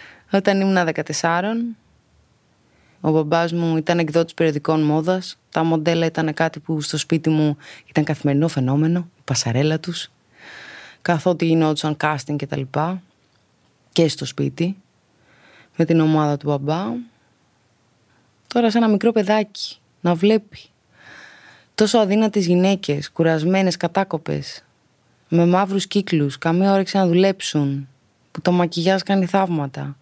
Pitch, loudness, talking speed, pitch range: 165 Hz, -20 LUFS, 125 wpm, 150-185 Hz